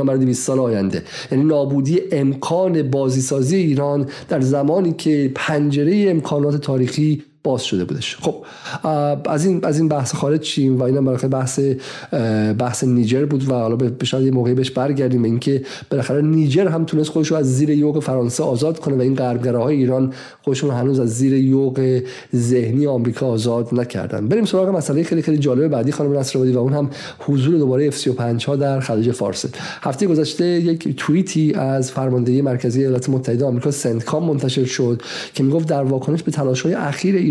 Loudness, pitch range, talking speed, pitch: -18 LUFS, 130-150 Hz, 170 wpm, 135 Hz